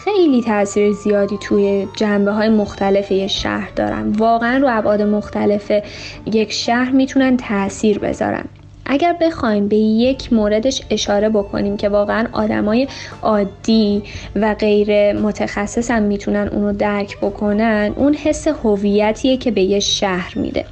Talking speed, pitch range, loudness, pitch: 135 wpm, 205-235 Hz, -16 LUFS, 210 Hz